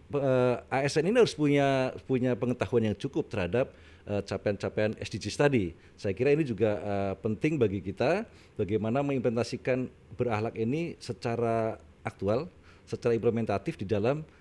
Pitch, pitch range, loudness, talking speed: 115 Hz, 105-130 Hz, -29 LUFS, 135 wpm